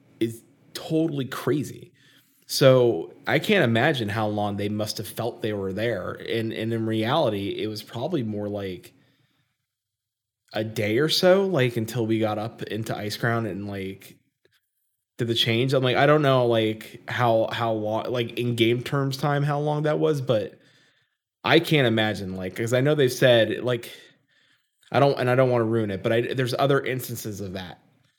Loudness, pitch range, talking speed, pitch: -24 LUFS, 110-135 Hz, 185 wpm, 115 Hz